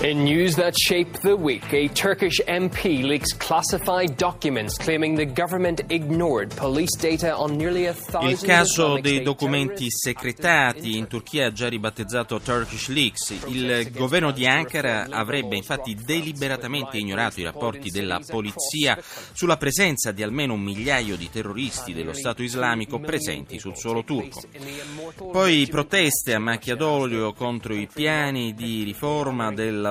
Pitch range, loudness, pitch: 115-155 Hz, -23 LUFS, 135 Hz